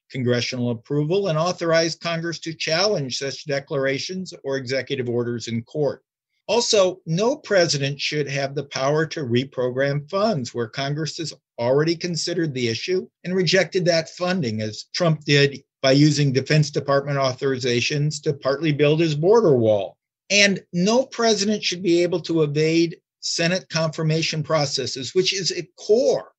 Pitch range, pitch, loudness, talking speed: 135-175 Hz, 155 Hz, -21 LUFS, 145 wpm